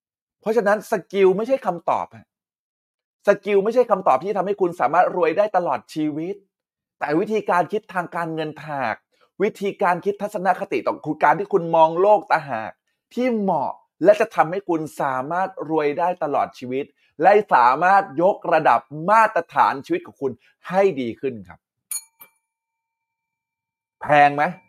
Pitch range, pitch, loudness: 155-210 Hz, 185 Hz, -20 LUFS